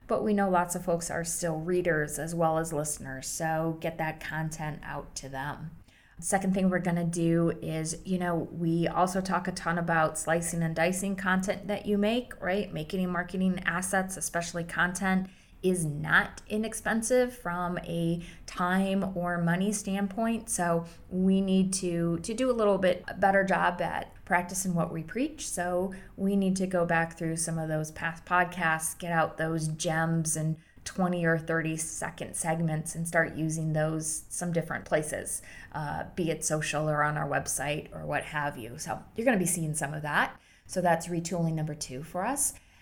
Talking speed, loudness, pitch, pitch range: 180 wpm, -30 LUFS, 170 Hz, 160-185 Hz